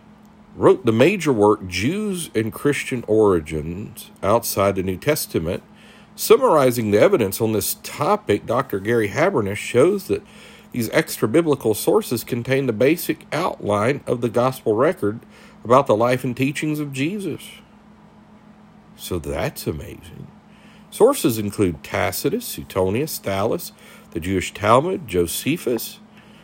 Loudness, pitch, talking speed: -20 LUFS, 125 Hz, 125 wpm